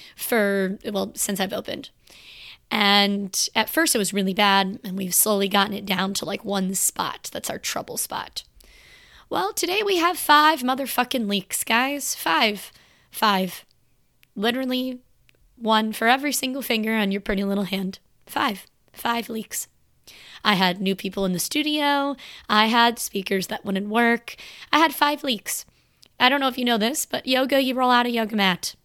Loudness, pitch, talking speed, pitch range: -22 LUFS, 220 Hz, 170 wpm, 200-260 Hz